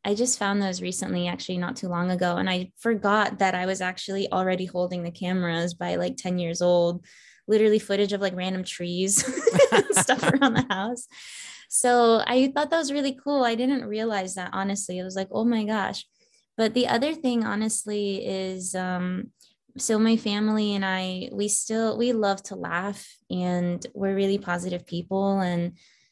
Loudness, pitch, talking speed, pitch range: -25 LUFS, 195 Hz, 180 wpm, 180-230 Hz